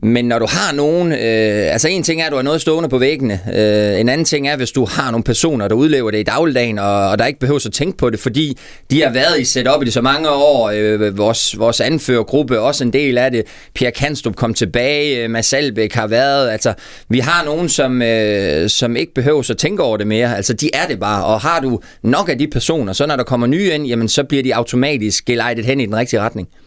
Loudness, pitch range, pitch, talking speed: -15 LUFS, 115-145 Hz, 125 Hz, 255 wpm